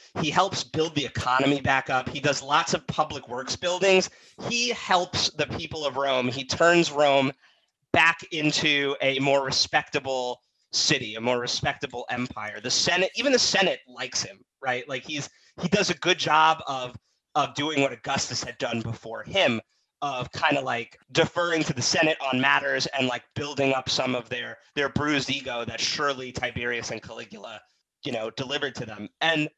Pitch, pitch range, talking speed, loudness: 140 Hz, 125-155 Hz, 180 wpm, -25 LUFS